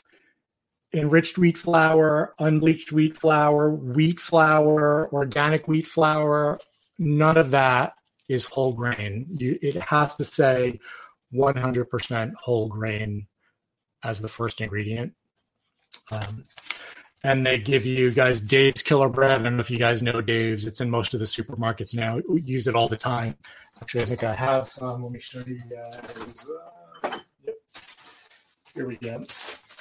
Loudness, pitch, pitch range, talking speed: -23 LUFS, 130 Hz, 115-150 Hz, 150 wpm